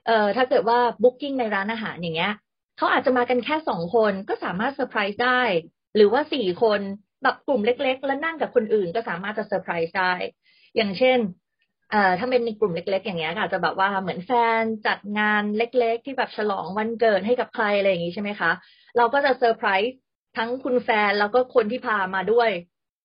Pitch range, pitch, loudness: 200-250 Hz, 225 Hz, -23 LUFS